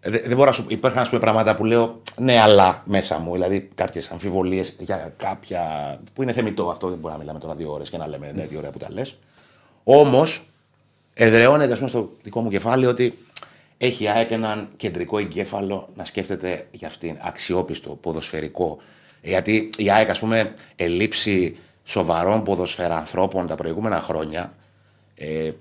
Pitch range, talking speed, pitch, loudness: 85-115 Hz, 165 wpm, 100 Hz, -21 LUFS